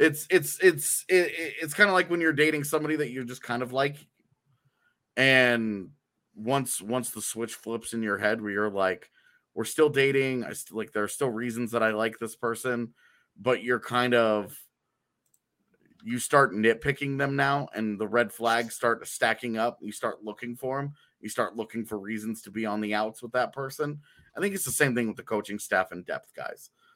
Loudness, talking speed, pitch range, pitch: -27 LUFS, 205 wpm, 110-140 Hz, 120 Hz